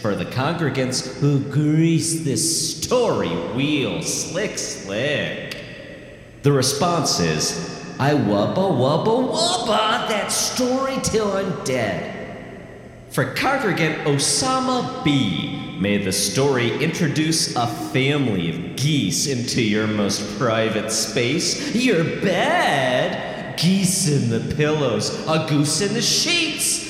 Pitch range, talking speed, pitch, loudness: 125-195 Hz, 110 wpm, 145 Hz, -20 LUFS